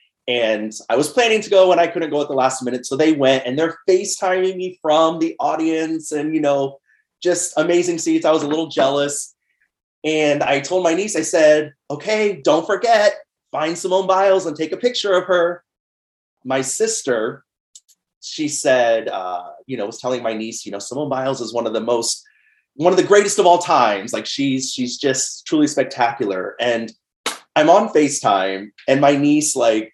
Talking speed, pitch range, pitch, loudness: 190 wpm, 130-180 Hz, 155 Hz, -18 LUFS